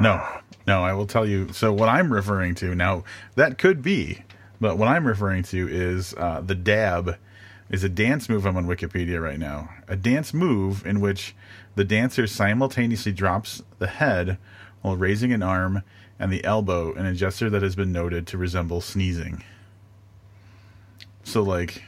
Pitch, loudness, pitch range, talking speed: 100 Hz, -24 LUFS, 90-105 Hz, 175 wpm